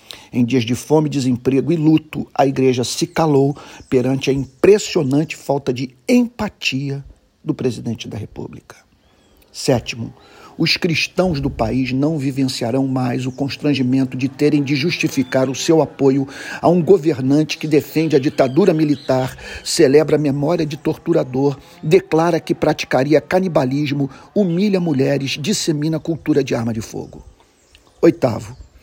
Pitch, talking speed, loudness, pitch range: 140 Hz, 135 wpm, -17 LUFS, 130-160 Hz